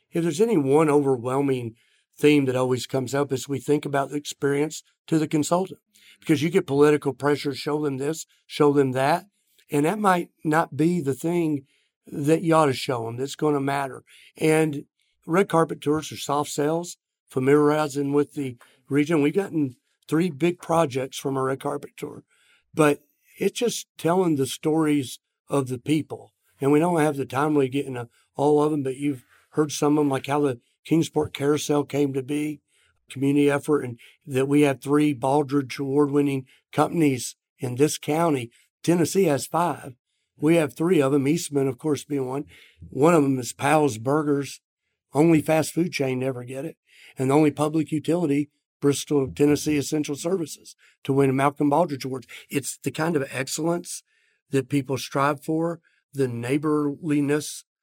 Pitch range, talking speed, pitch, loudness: 135-155 Hz, 175 wpm, 145 Hz, -24 LUFS